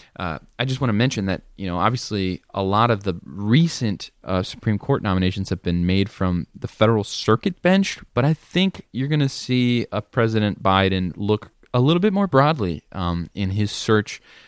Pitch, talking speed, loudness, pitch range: 110 Hz, 195 wpm, -21 LUFS, 95-125 Hz